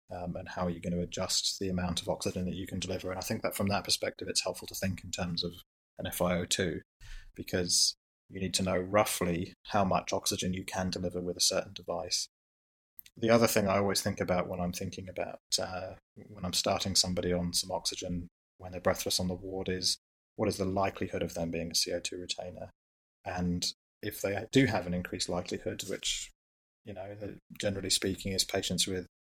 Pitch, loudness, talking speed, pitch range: 90 Hz, -32 LUFS, 205 wpm, 90-95 Hz